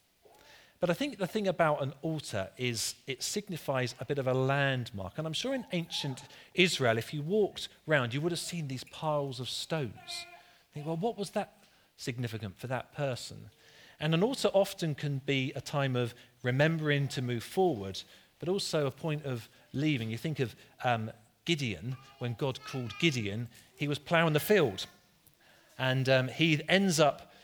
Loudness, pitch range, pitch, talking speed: -32 LUFS, 125-165 Hz, 140 Hz, 180 wpm